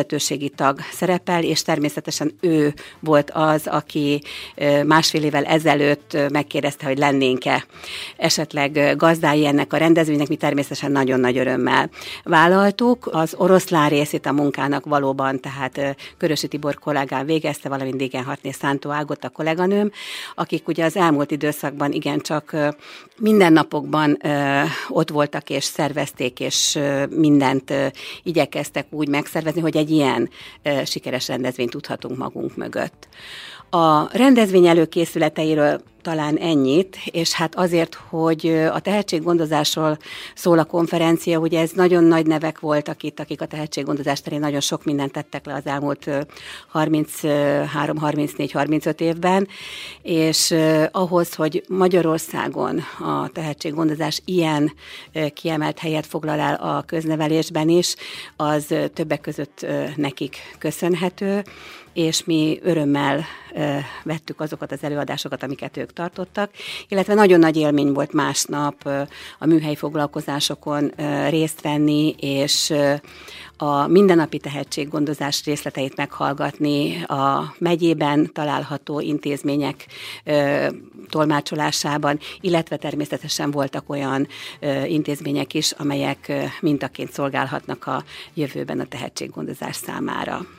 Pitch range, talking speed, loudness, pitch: 145-165 Hz, 110 wpm, -20 LUFS, 150 Hz